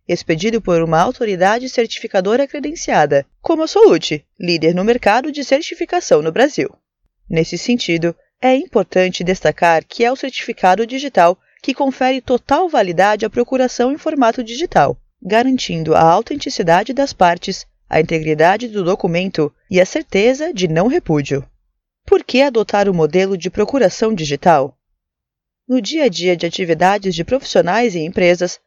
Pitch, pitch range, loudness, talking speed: 210 Hz, 175-260 Hz, -15 LUFS, 145 wpm